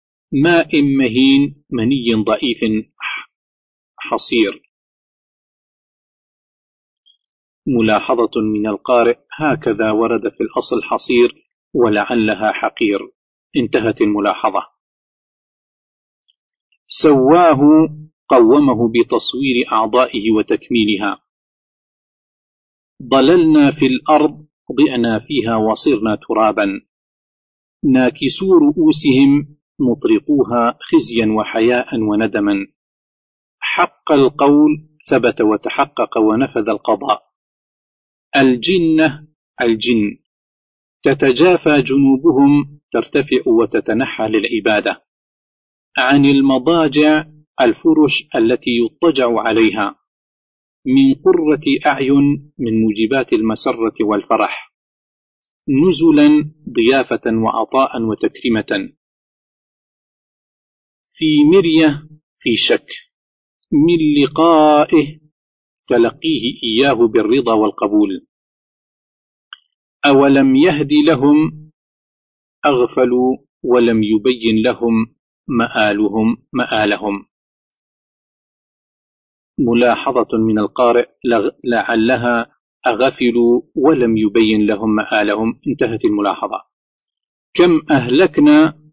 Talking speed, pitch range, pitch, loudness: 65 wpm, 115-160 Hz, 140 Hz, -14 LUFS